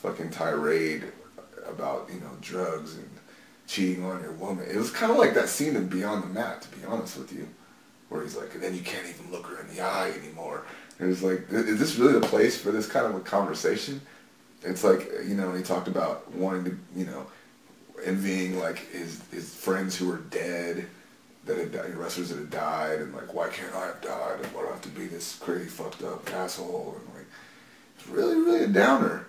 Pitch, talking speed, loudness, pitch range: 95 Hz, 220 wpm, -29 LUFS, 90-95 Hz